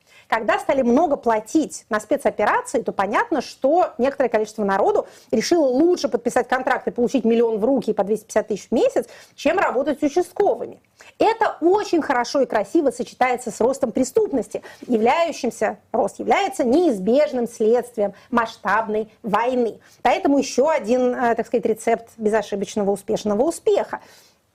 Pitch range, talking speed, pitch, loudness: 220-295 Hz, 135 wpm, 245 Hz, -21 LUFS